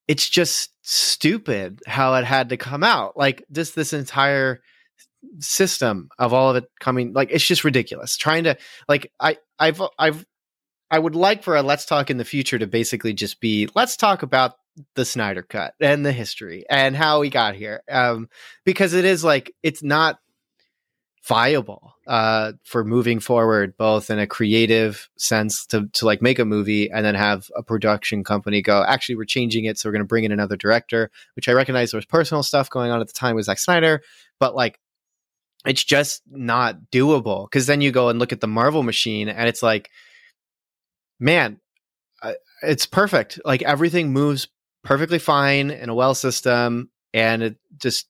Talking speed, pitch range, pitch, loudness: 185 wpm, 115-150 Hz, 130 Hz, -20 LUFS